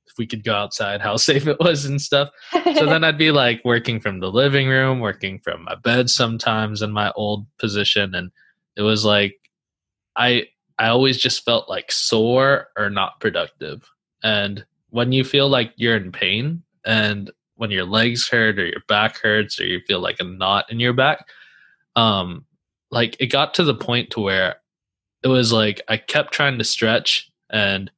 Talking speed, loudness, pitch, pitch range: 190 wpm, -19 LUFS, 115 Hz, 105-130 Hz